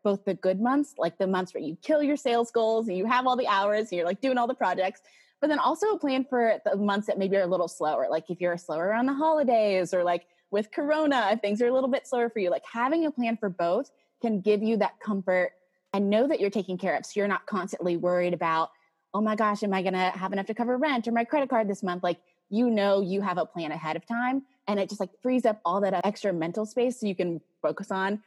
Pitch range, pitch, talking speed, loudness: 185-240 Hz, 205 Hz, 270 wpm, -27 LUFS